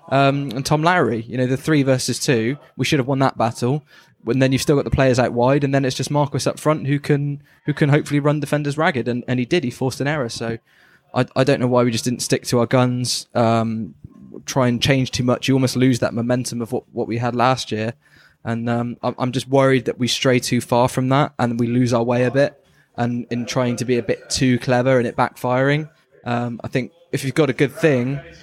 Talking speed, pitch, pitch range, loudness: 250 wpm, 130 Hz, 120-140 Hz, -19 LUFS